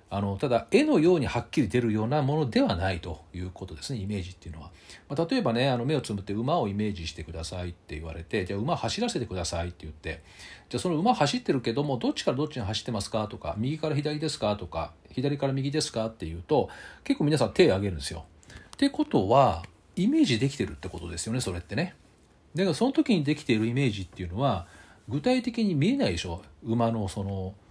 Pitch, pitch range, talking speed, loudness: 105 Hz, 90-140 Hz, 475 characters per minute, -28 LUFS